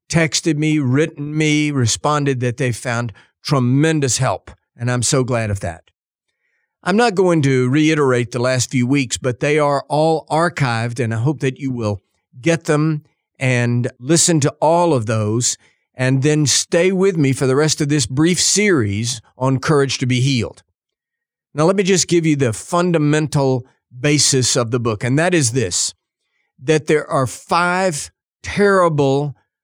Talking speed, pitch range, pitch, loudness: 165 wpm, 125-160 Hz, 140 Hz, -17 LUFS